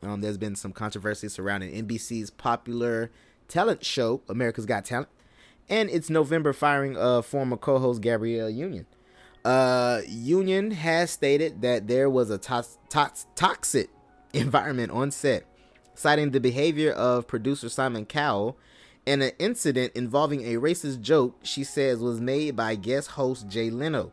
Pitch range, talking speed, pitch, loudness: 115-145 Hz, 150 wpm, 125 Hz, -26 LUFS